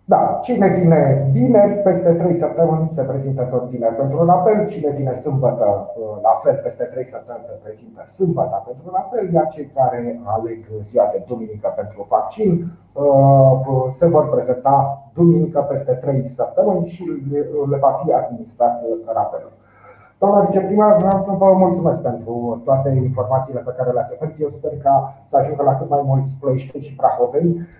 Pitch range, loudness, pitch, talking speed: 130-175 Hz, -17 LUFS, 140 Hz, 160 wpm